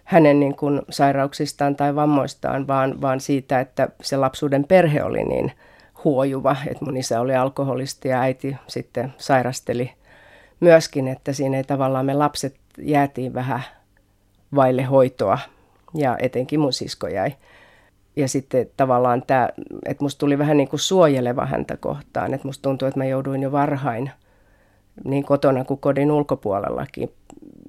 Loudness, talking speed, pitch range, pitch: -21 LUFS, 145 wpm, 130-145 Hz, 135 Hz